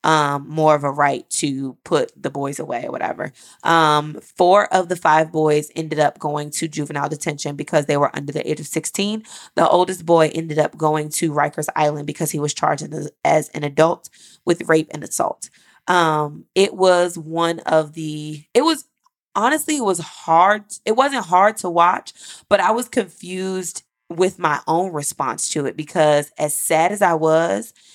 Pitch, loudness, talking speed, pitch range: 160 Hz, -19 LUFS, 185 wpm, 150-180 Hz